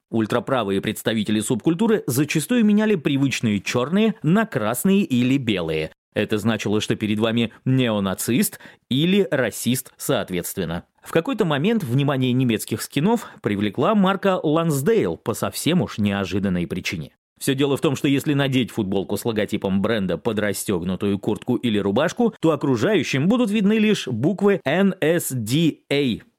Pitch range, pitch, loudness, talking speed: 110-170 Hz, 135 Hz, -21 LUFS, 130 wpm